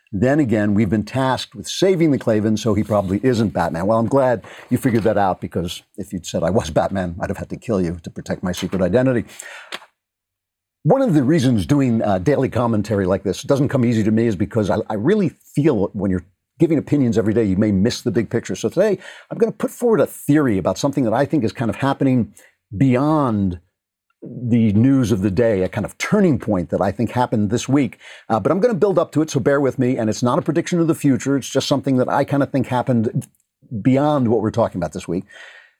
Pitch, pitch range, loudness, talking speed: 115 Hz, 105-140 Hz, -19 LUFS, 240 wpm